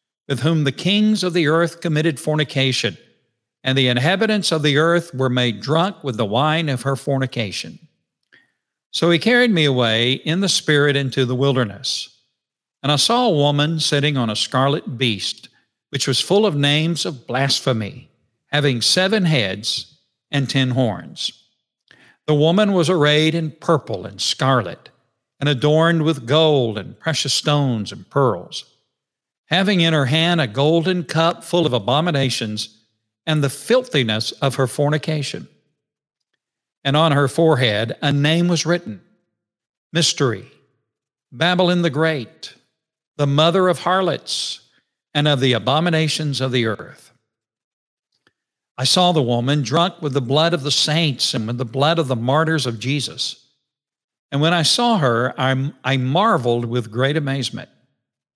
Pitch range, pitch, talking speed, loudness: 130-165 Hz, 145 Hz, 150 wpm, -18 LUFS